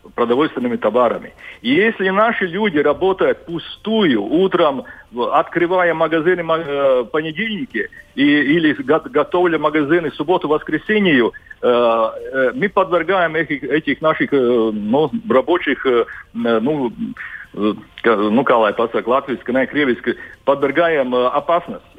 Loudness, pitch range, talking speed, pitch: -17 LUFS, 145-220 Hz, 80 wpm, 170 Hz